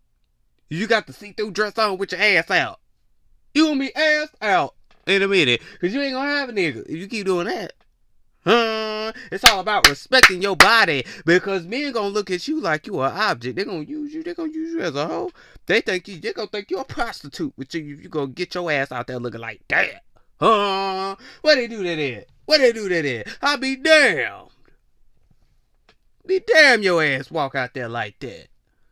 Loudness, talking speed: -19 LUFS, 220 wpm